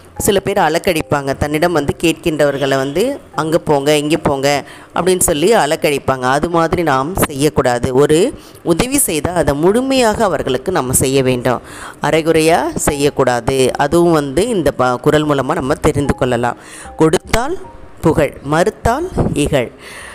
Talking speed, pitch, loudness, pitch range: 125 wpm, 150 Hz, -14 LUFS, 135-170 Hz